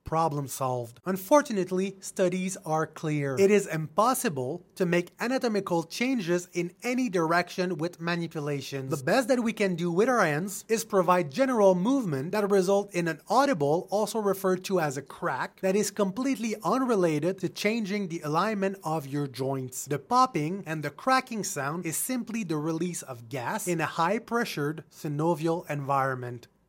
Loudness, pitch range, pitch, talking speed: -28 LUFS, 160-210 Hz, 180 Hz, 160 wpm